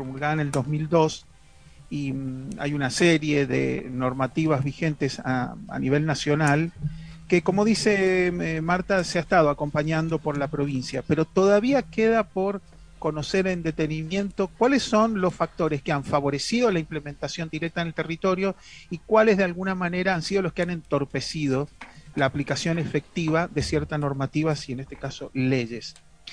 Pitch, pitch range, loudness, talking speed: 155 Hz, 140-180 Hz, -25 LUFS, 155 wpm